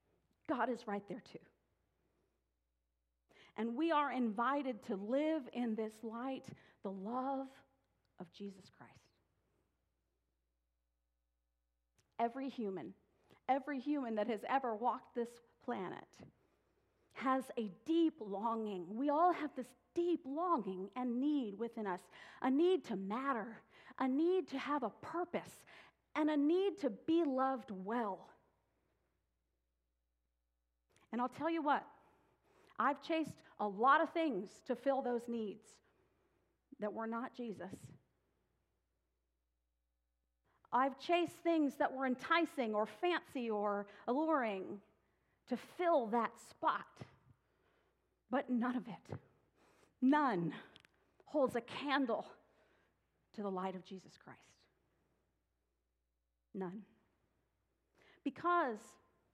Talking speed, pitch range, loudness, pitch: 110 wpm, 185-275 Hz, -39 LUFS, 235 Hz